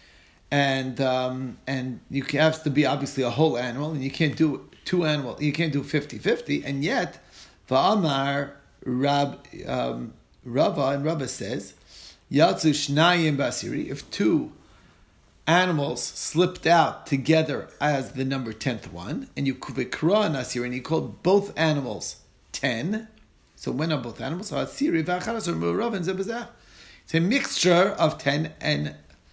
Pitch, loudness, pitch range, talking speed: 140 Hz, -25 LUFS, 125-160 Hz, 125 wpm